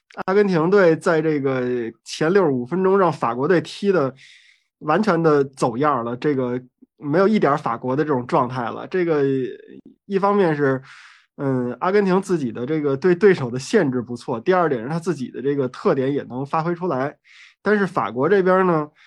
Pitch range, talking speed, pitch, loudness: 130-185 Hz, 275 characters per minute, 155 Hz, -20 LUFS